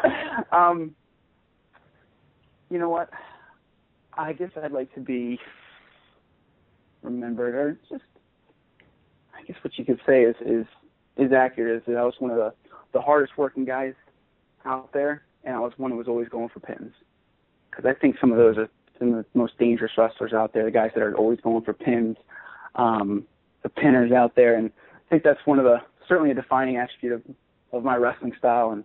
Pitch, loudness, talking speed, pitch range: 125 Hz, -23 LUFS, 190 wpm, 115-140 Hz